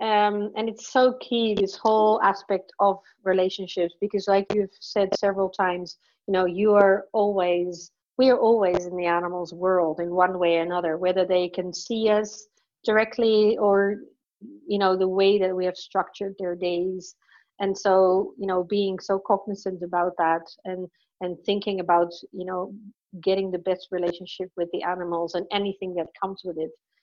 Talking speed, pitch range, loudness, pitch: 175 wpm, 180-205 Hz, -24 LUFS, 190 Hz